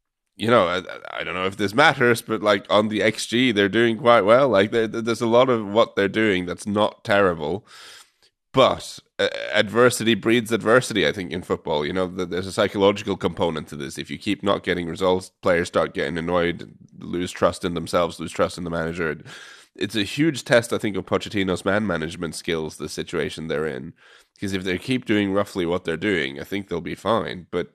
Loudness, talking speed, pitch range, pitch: -22 LUFS, 205 wpm, 90-115 Hz, 100 Hz